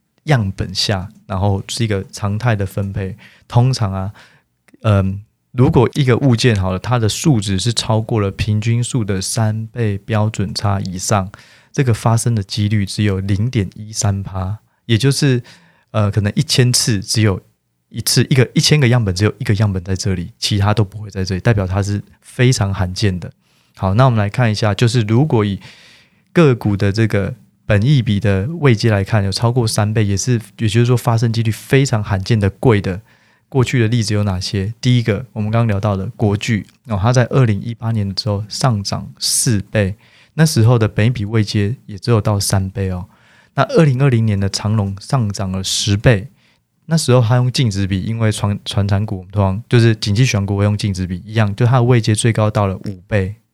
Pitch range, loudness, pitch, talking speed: 100-120 Hz, -16 LUFS, 110 Hz, 290 characters per minute